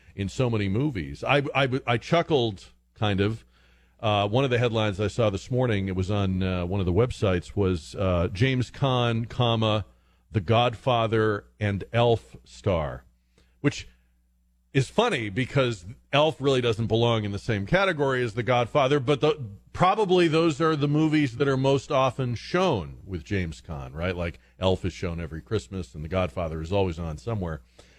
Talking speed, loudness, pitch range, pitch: 175 wpm, -25 LUFS, 90-130 Hz, 110 Hz